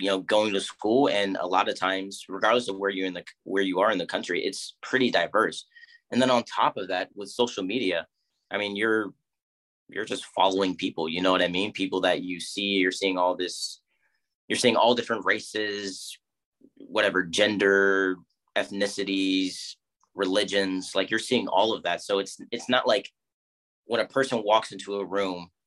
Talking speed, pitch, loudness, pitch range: 190 wpm, 95 Hz, -26 LUFS, 95-105 Hz